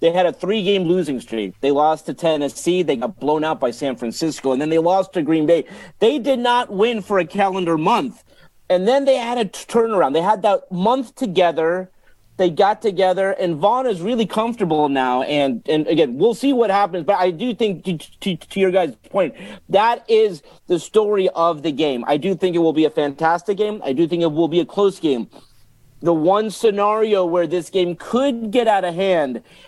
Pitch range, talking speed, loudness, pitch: 160-215 Hz, 215 wpm, -19 LUFS, 185 Hz